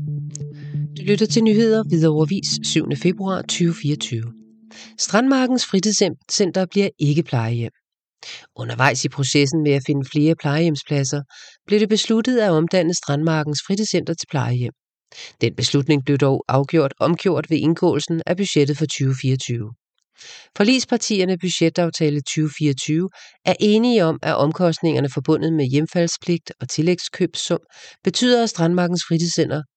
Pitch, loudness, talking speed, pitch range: 160 Hz, -19 LUFS, 120 wpm, 145-185 Hz